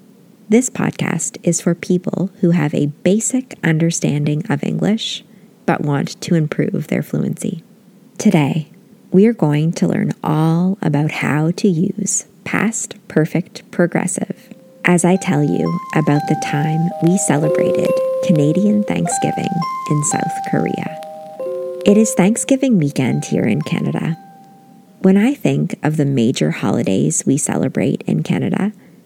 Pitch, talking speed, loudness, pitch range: 185 Hz, 130 wpm, -17 LUFS, 160-205 Hz